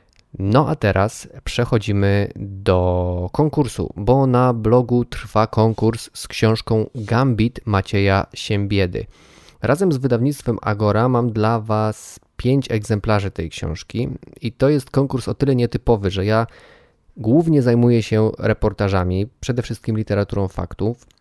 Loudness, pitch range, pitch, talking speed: -19 LUFS, 100-125 Hz, 110 Hz, 125 wpm